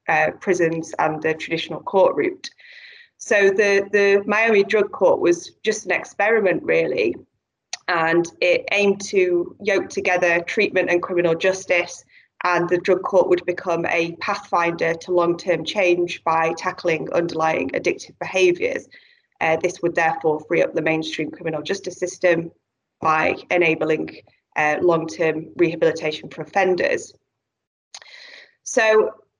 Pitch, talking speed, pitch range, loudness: 180 Hz, 135 wpm, 165-210 Hz, -20 LUFS